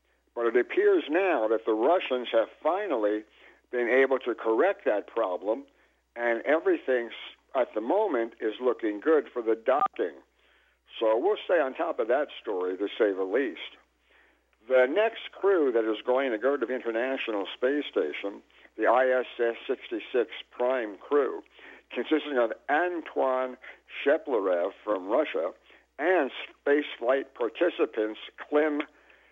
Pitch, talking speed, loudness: 130 Hz, 135 wpm, -28 LUFS